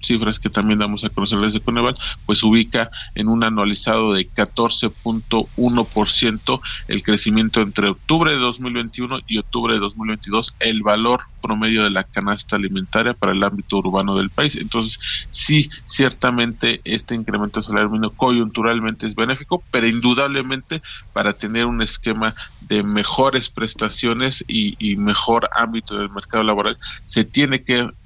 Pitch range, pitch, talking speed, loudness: 105-120 Hz, 110 Hz, 140 wpm, -19 LUFS